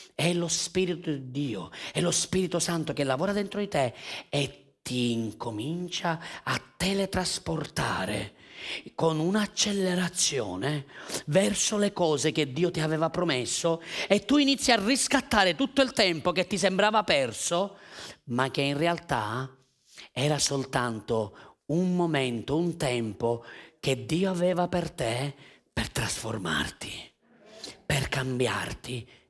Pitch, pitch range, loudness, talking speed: 165 Hz, 130-185 Hz, -28 LUFS, 125 wpm